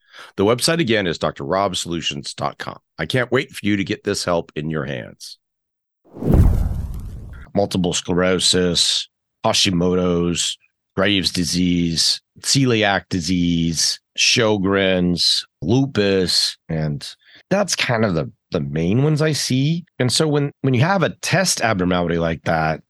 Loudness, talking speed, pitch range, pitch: -19 LUFS, 125 wpm, 85-115 Hz, 95 Hz